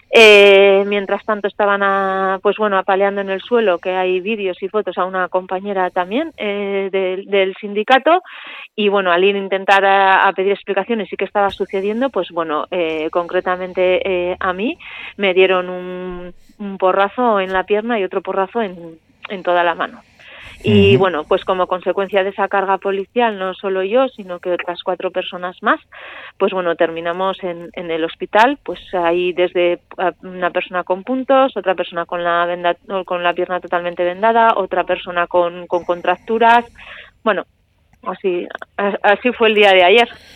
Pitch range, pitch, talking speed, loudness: 180-205 Hz, 190 Hz, 170 wpm, -16 LUFS